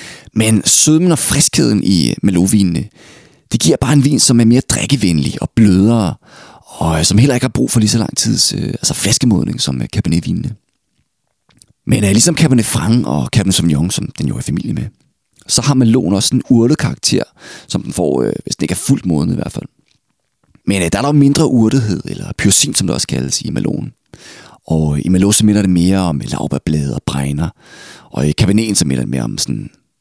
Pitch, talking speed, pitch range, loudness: 110 Hz, 200 wpm, 90-130 Hz, -13 LUFS